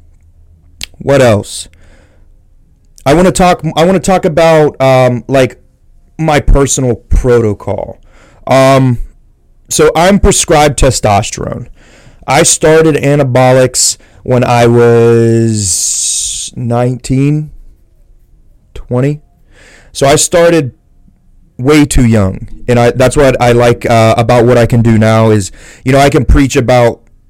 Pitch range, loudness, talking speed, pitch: 110-140 Hz, -8 LUFS, 120 wpm, 125 Hz